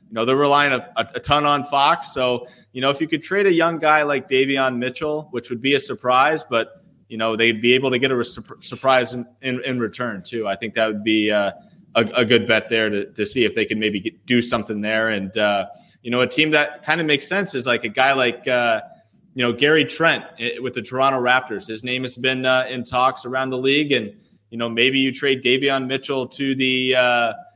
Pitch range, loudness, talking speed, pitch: 120-140 Hz, -19 LUFS, 240 wpm, 130 Hz